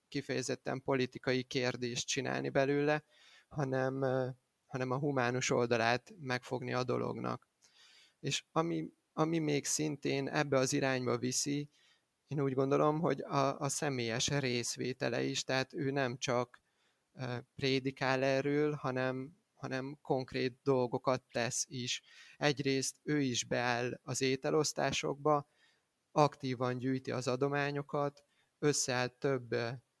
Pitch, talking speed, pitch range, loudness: 135 Hz, 110 wpm, 125-145 Hz, -35 LUFS